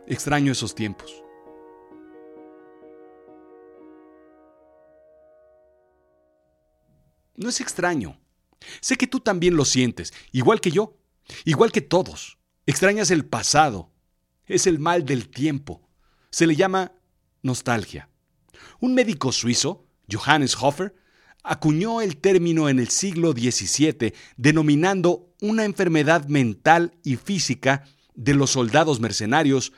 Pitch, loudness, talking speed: 135 Hz, -21 LUFS, 105 wpm